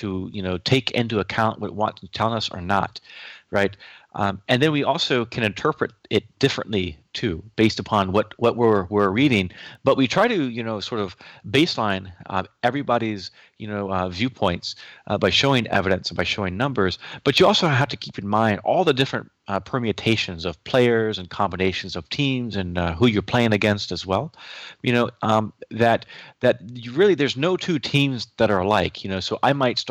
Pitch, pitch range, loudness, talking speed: 110 Hz, 95-125 Hz, -22 LUFS, 205 wpm